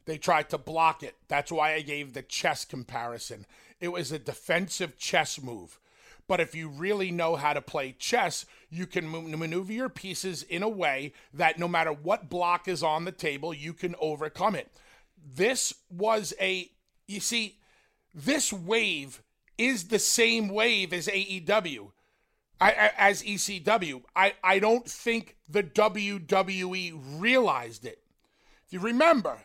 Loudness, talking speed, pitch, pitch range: -28 LUFS, 155 wpm, 185 Hz, 160-210 Hz